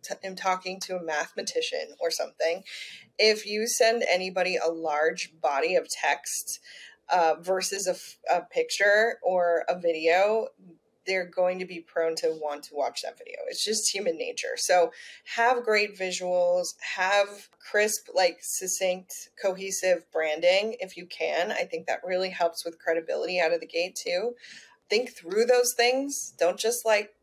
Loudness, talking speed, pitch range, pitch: -27 LUFS, 160 wpm, 180-265 Hz, 195 Hz